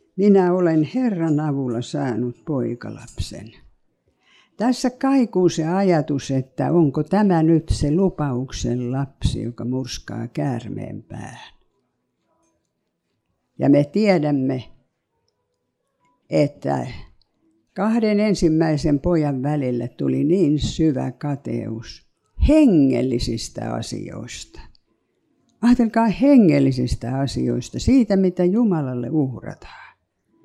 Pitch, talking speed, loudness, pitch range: 145 Hz, 85 wpm, -20 LUFS, 125-185 Hz